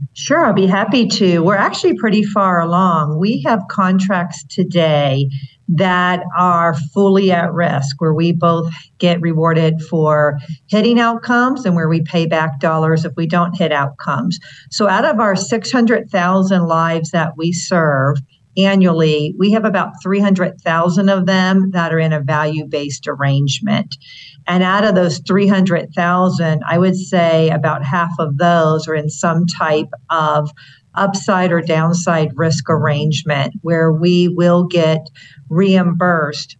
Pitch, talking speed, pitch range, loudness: 170 Hz, 145 wpm, 155-190 Hz, -15 LUFS